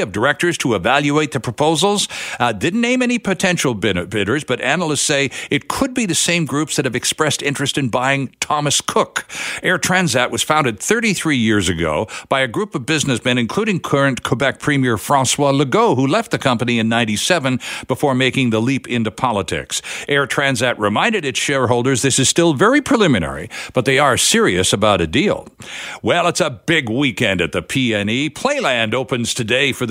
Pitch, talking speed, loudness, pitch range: 140 Hz, 180 wpm, -16 LUFS, 125-160 Hz